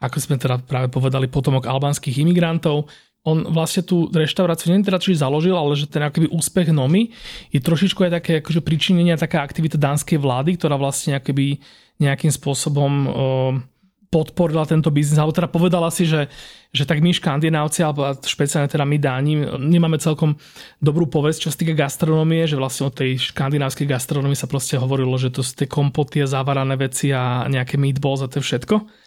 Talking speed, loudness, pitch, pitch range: 180 wpm, -19 LUFS, 150 Hz, 140-165 Hz